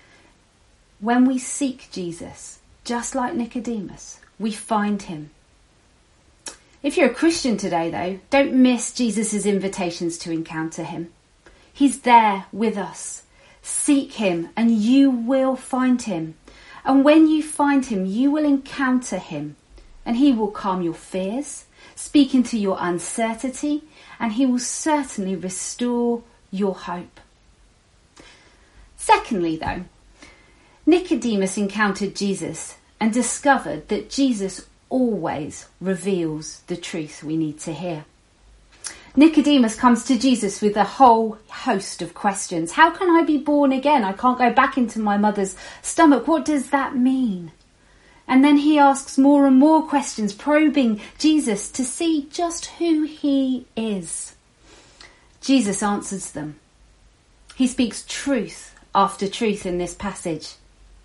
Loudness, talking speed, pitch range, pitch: -20 LUFS, 130 wpm, 190-275 Hz, 235 Hz